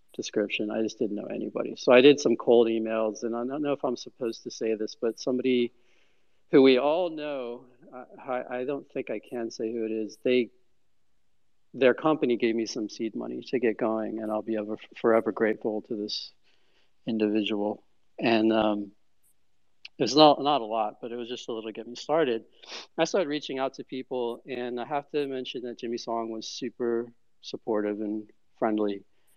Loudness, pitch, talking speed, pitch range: -27 LUFS, 115 Hz, 190 wpm, 110-125 Hz